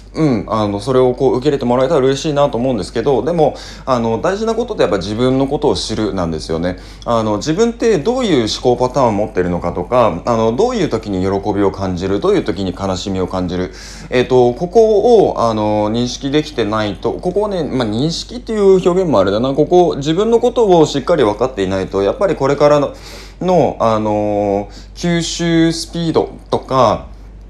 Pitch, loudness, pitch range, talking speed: 120 Hz, -15 LUFS, 100-155 Hz, 405 characters per minute